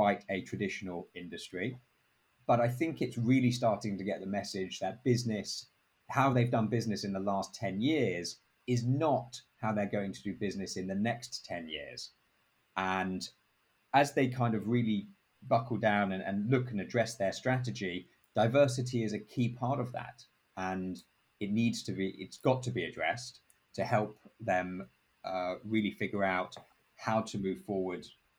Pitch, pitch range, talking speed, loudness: 105 Hz, 95-120 Hz, 170 wpm, -33 LUFS